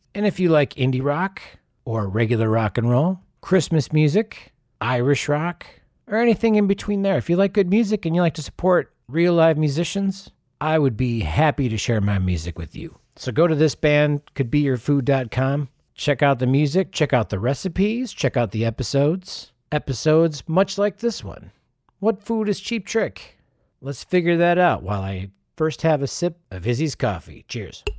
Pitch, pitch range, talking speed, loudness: 150 Hz, 125-180 Hz, 180 wpm, -21 LUFS